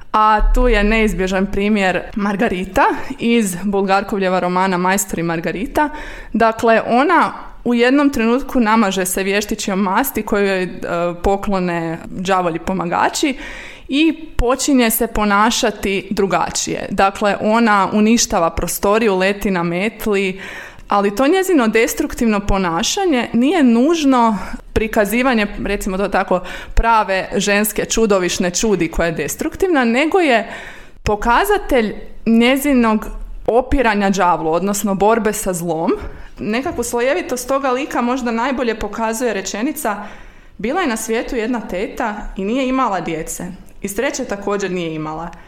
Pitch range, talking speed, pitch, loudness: 195-245 Hz, 115 wpm, 215 Hz, -17 LUFS